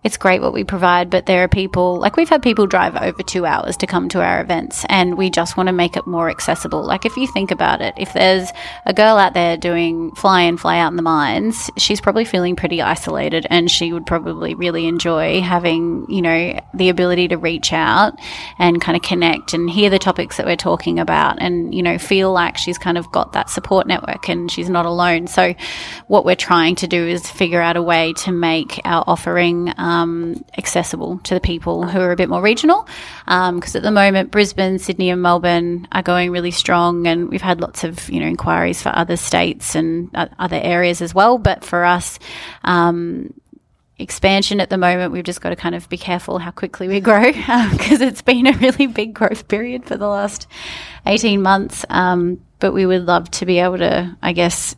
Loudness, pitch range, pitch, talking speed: -16 LUFS, 170-195 Hz, 180 Hz, 220 wpm